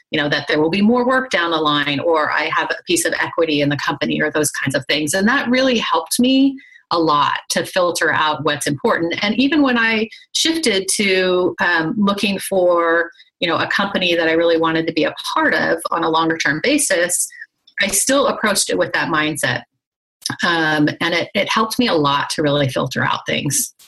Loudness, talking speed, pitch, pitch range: -17 LUFS, 215 wpm, 185 Hz, 160-250 Hz